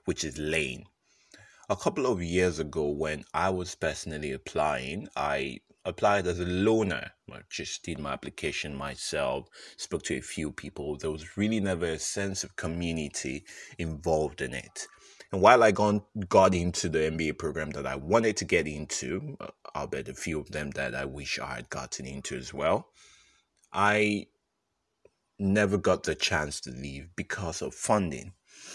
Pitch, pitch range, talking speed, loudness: 85 Hz, 75-100 Hz, 165 wpm, -29 LUFS